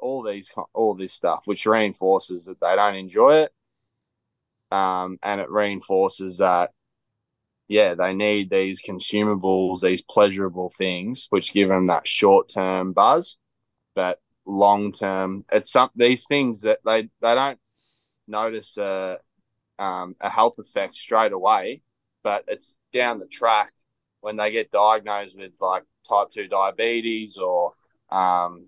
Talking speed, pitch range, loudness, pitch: 140 wpm, 95-110 Hz, -22 LUFS, 100 Hz